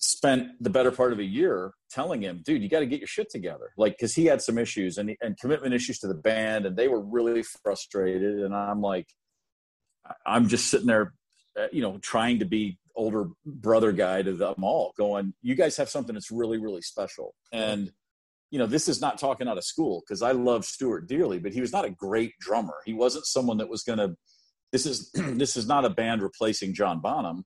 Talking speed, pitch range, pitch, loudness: 220 wpm, 105-130 Hz, 115 Hz, -27 LUFS